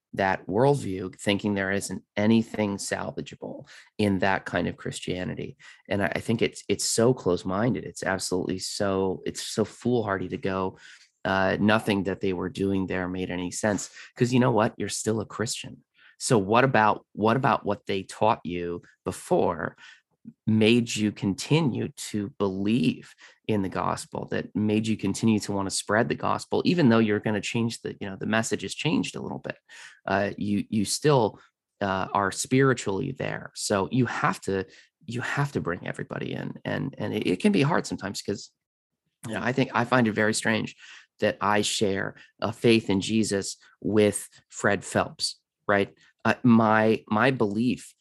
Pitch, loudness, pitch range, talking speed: 105 Hz, -26 LUFS, 95-115 Hz, 175 wpm